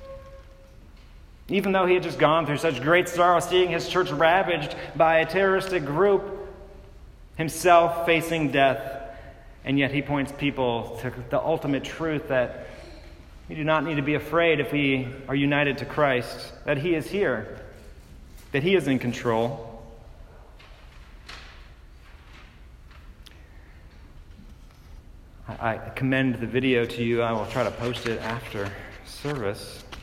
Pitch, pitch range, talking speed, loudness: 130 Hz, 100-160 Hz, 135 wpm, -24 LUFS